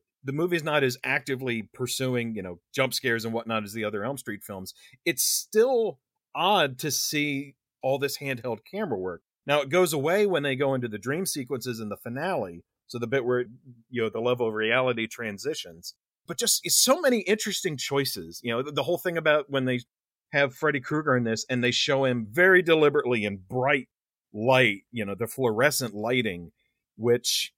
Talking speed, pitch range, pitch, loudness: 190 wpm, 115-150 Hz, 130 Hz, -26 LUFS